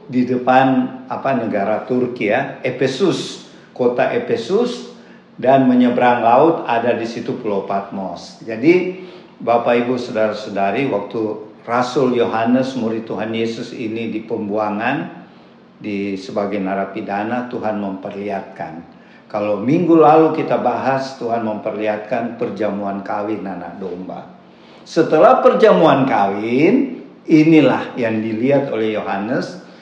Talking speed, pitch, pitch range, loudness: 110 wpm, 115 Hz, 105-125 Hz, -17 LUFS